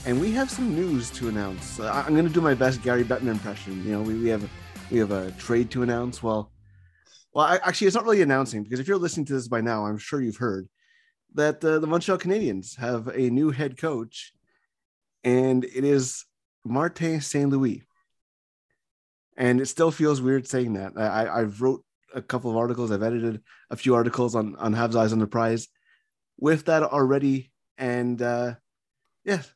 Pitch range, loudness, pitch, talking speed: 110-145 Hz, -25 LUFS, 125 Hz, 195 wpm